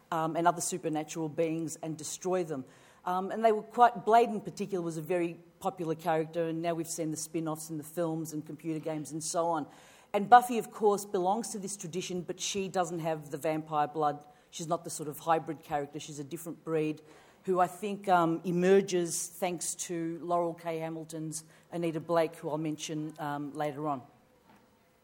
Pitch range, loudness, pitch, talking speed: 155-180 Hz, -32 LUFS, 165 Hz, 195 wpm